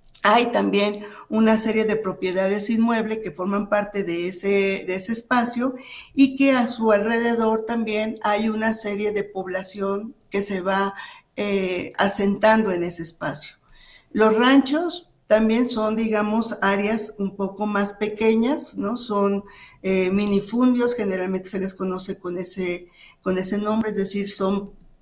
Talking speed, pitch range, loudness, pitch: 145 wpm, 195-225 Hz, -21 LUFS, 205 Hz